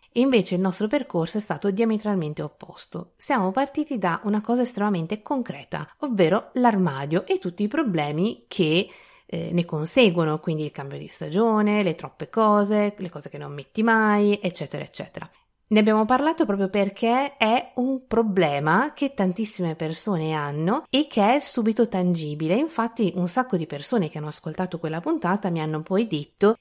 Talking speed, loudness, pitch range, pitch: 160 wpm, -23 LUFS, 165-230 Hz, 200 Hz